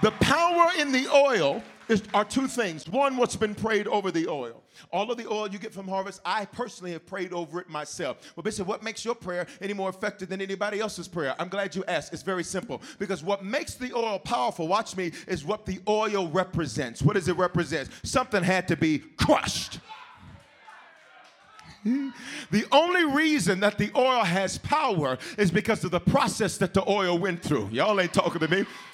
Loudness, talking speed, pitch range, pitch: -27 LUFS, 200 wpm, 180-220 Hz, 200 Hz